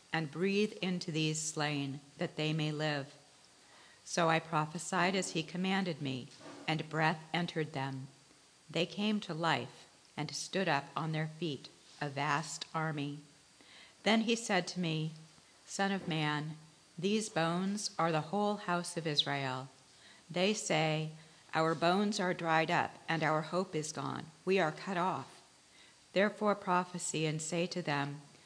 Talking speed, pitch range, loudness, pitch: 150 wpm, 150-180 Hz, -35 LUFS, 160 Hz